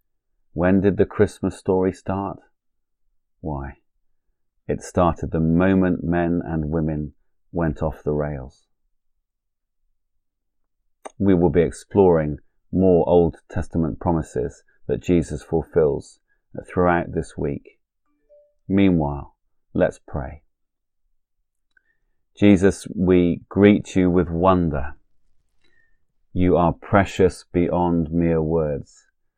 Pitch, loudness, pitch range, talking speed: 85 Hz, -21 LUFS, 80-95 Hz, 95 wpm